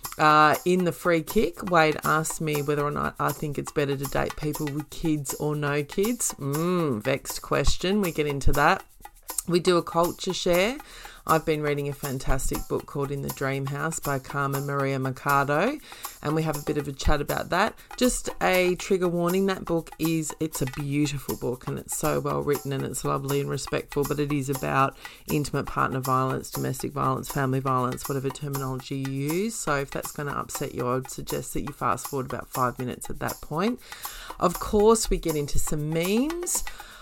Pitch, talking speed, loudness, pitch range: 150 Hz, 200 wpm, -26 LUFS, 140-170 Hz